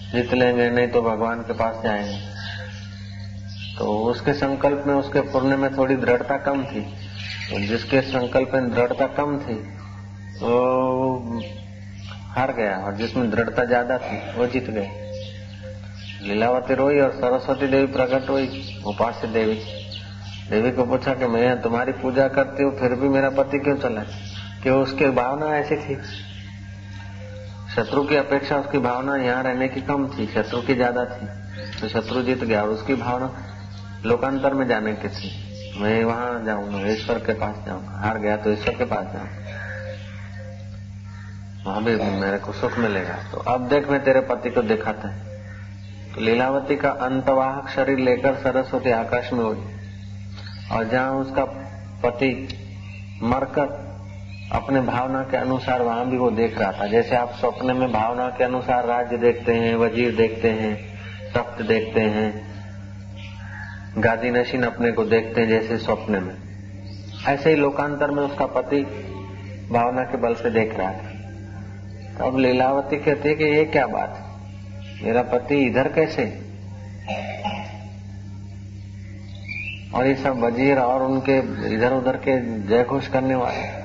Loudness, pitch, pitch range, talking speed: -22 LUFS, 115 Hz, 100-130 Hz, 150 wpm